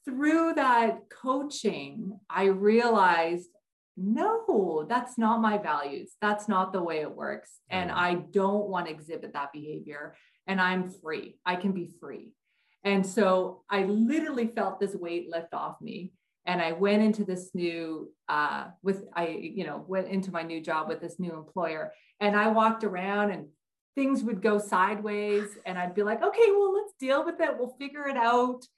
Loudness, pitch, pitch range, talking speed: -28 LUFS, 200 Hz, 180-230 Hz, 175 wpm